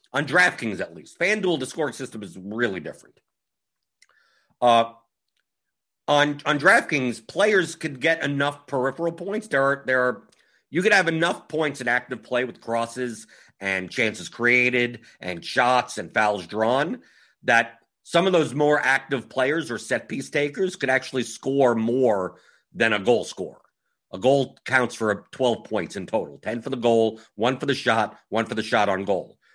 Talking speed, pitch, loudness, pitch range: 170 wpm, 125 Hz, -23 LUFS, 115-145 Hz